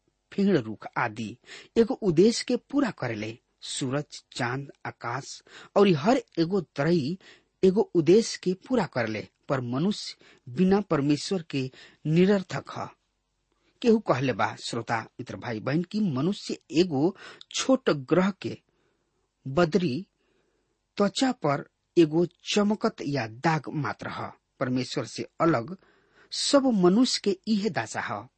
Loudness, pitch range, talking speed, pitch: -26 LUFS, 130-215 Hz, 120 wpm, 175 Hz